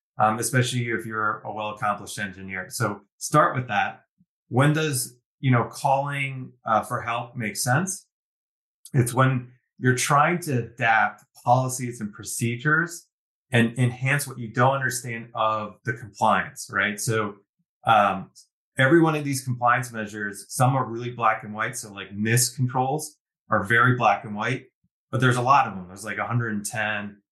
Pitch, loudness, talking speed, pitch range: 120 Hz, -24 LUFS, 160 wpm, 110-130 Hz